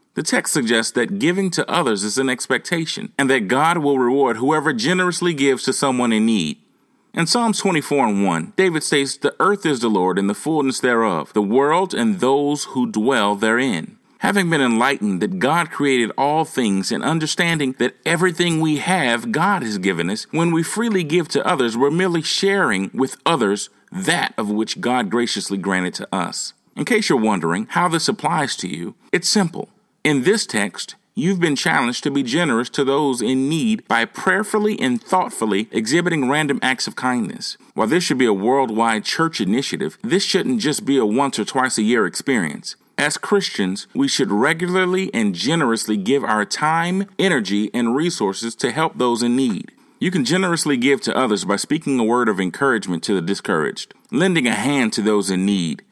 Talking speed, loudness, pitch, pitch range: 185 wpm, -19 LUFS, 145 Hz, 120-185 Hz